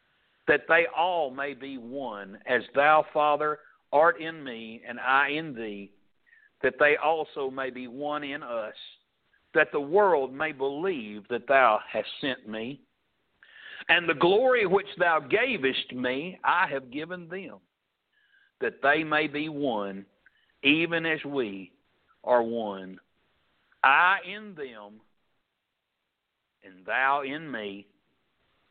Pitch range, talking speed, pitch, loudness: 120-155 Hz, 130 wpm, 140 Hz, -26 LUFS